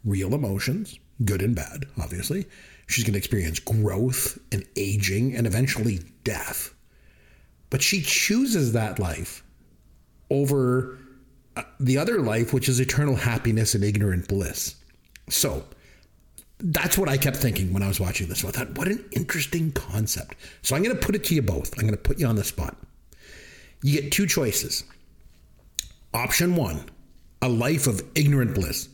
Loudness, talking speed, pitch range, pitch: -25 LUFS, 160 wpm, 95-140 Hz, 115 Hz